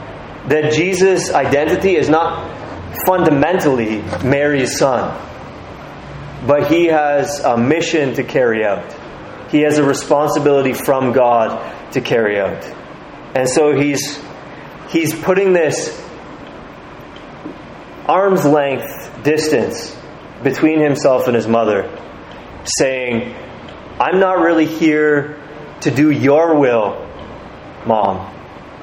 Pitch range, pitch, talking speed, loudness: 135-160 Hz, 150 Hz, 100 wpm, -15 LUFS